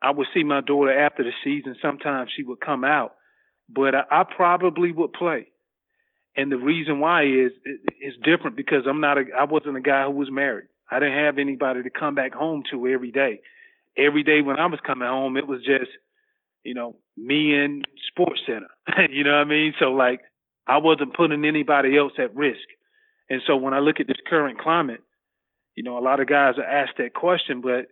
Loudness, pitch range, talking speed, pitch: -22 LUFS, 135-155 Hz, 215 wpm, 145 Hz